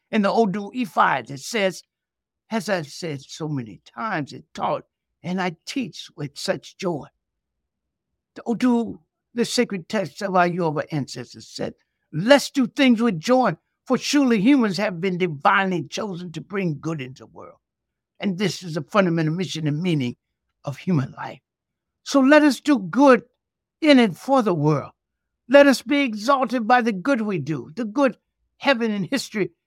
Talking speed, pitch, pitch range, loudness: 170 wpm, 195 Hz, 155-245 Hz, -21 LUFS